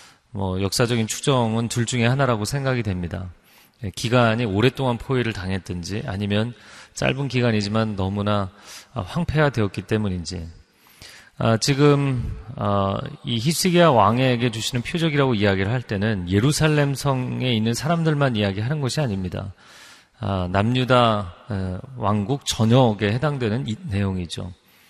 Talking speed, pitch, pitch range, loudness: 295 characters per minute, 115 Hz, 100-130 Hz, -22 LUFS